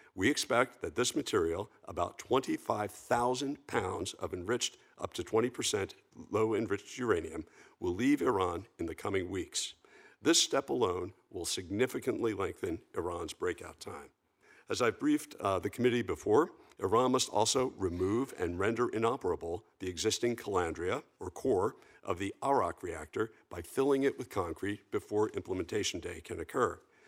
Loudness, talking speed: -34 LUFS, 145 wpm